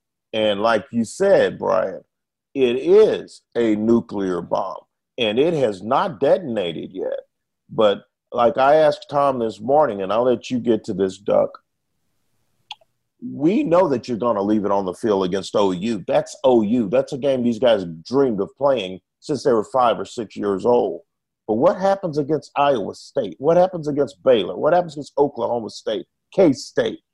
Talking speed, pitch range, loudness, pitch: 175 wpm, 110-155 Hz, -20 LUFS, 125 Hz